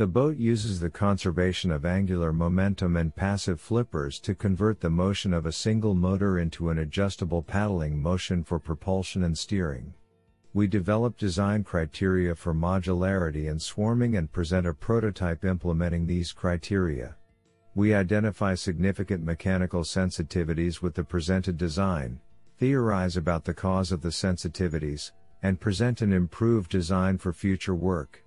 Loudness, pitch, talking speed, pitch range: -27 LUFS, 95 Hz, 140 wpm, 85-100 Hz